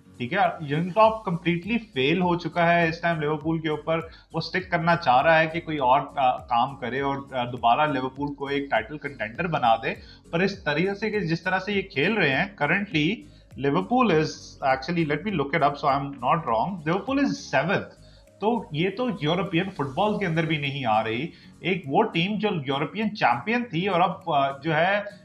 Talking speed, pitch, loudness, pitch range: 200 wpm, 165 Hz, -24 LUFS, 145-195 Hz